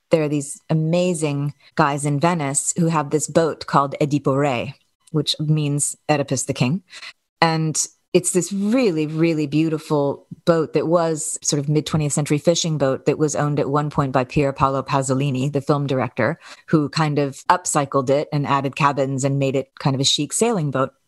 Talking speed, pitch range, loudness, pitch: 180 wpm, 140-160 Hz, -20 LUFS, 150 Hz